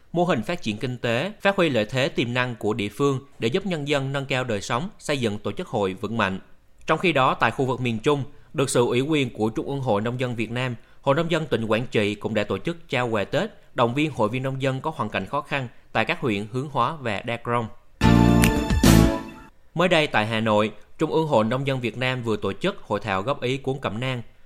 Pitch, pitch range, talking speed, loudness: 125 Hz, 110-145 Hz, 255 wpm, -24 LUFS